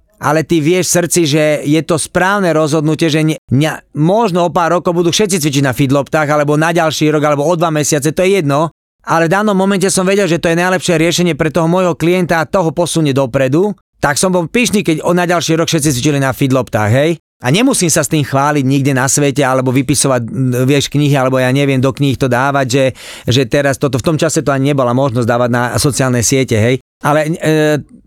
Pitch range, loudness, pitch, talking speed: 140-170 Hz, -12 LUFS, 155 Hz, 220 wpm